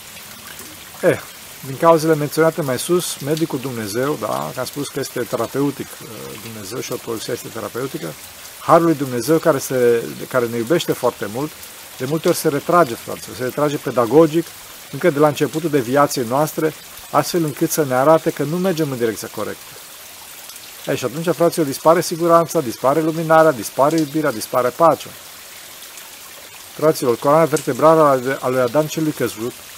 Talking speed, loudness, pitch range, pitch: 160 wpm, -18 LUFS, 130-160 Hz, 150 Hz